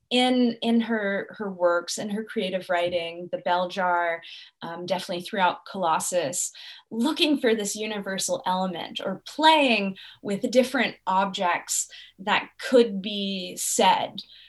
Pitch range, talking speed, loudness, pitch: 180-230 Hz, 125 wpm, -25 LUFS, 195 Hz